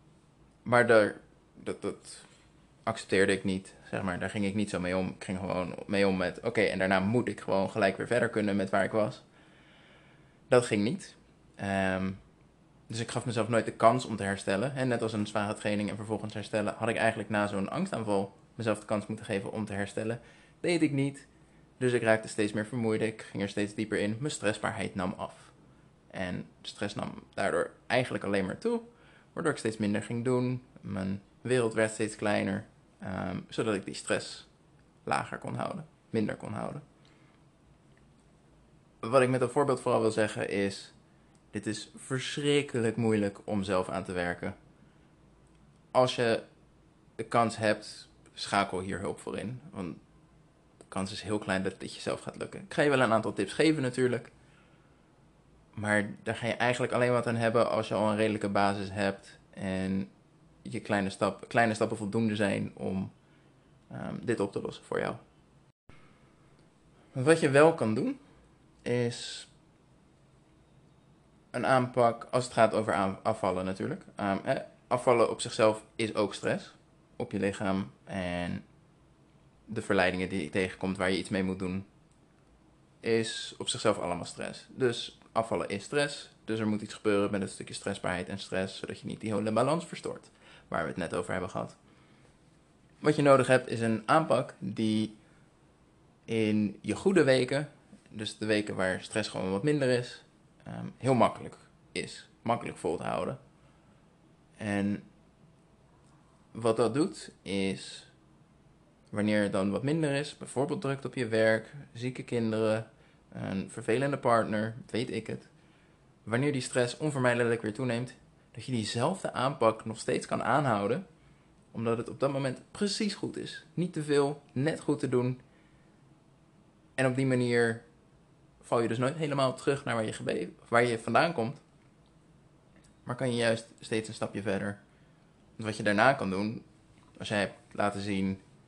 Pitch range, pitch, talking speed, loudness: 100-125 Hz, 110 Hz, 170 wpm, -31 LUFS